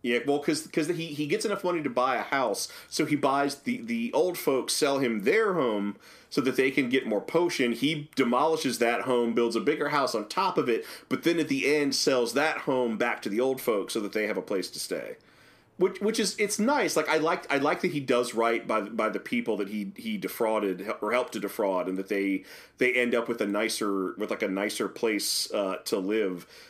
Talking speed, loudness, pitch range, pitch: 240 wpm, -27 LUFS, 120-170 Hz, 140 Hz